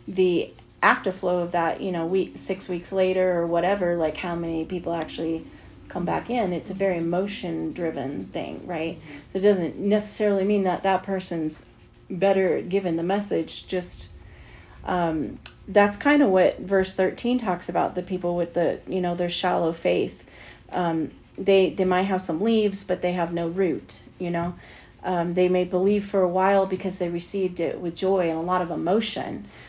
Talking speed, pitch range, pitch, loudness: 180 wpm, 170-195 Hz, 180 Hz, -25 LUFS